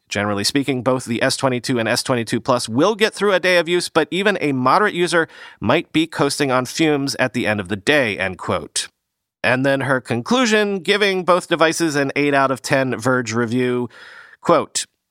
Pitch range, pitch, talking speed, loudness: 125-165 Hz, 135 Hz, 190 wpm, -18 LUFS